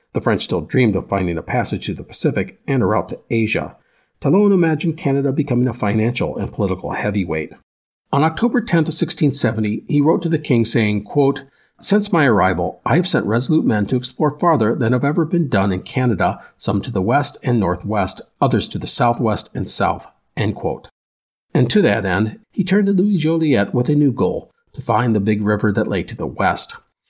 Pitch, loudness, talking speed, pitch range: 125 Hz, -18 LUFS, 200 wpm, 105-155 Hz